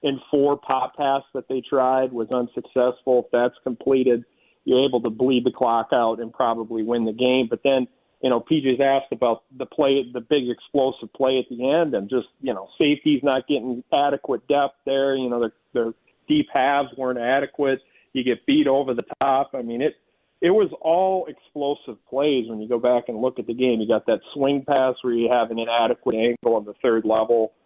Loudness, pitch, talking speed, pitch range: -22 LUFS, 130 Hz, 210 wpm, 120-135 Hz